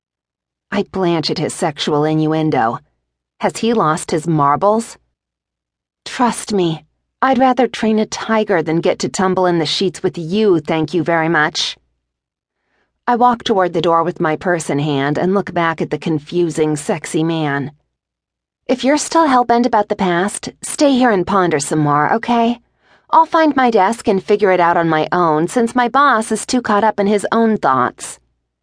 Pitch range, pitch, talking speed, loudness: 155-225 Hz, 180 Hz, 180 wpm, -15 LUFS